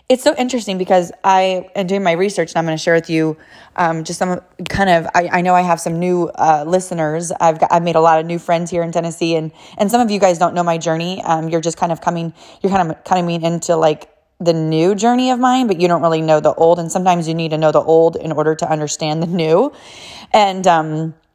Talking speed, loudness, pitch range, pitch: 260 wpm, -16 LUFS, 160-185 Hz, 170 Hz